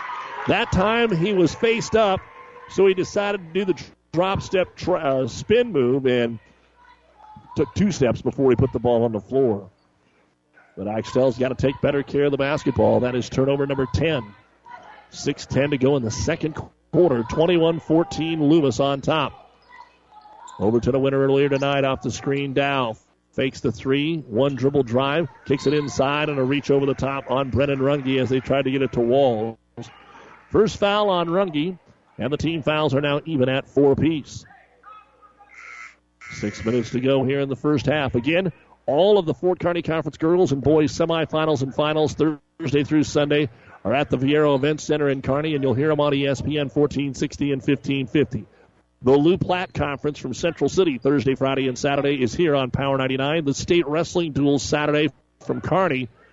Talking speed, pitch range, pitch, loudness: 185 wpm, 130-160 Hz, 140 Hz, -21 LUFS